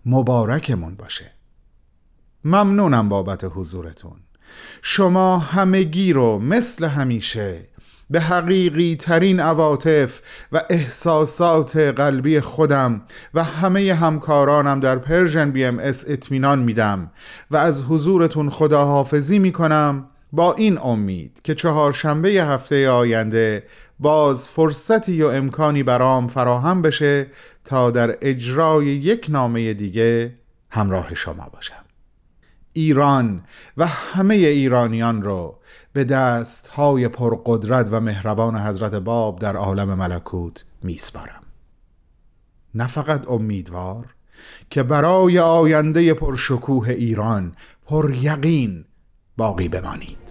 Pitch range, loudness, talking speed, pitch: 115-155 Hz, -18 LUFS, 100 wpm, 135 Hz